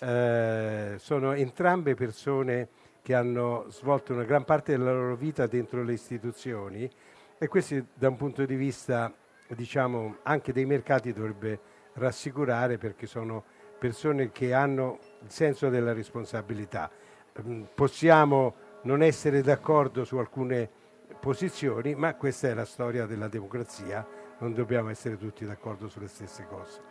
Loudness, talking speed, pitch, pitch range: -29 LUFS, 135 wpm, 125 Hz, 115-140 Hz